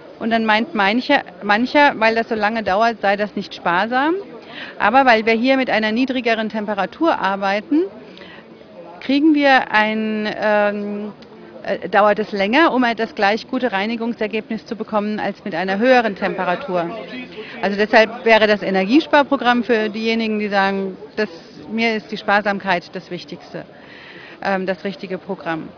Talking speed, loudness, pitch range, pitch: 150 wpm, -18 LUFS, 200-235 Hz, 215 Hz